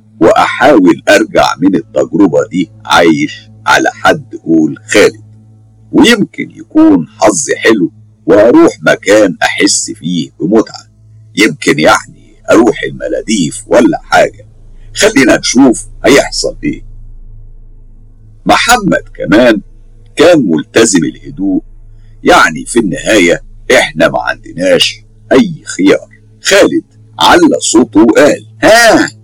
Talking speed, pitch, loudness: 95 wpm, 110 Hz, -8 LUFS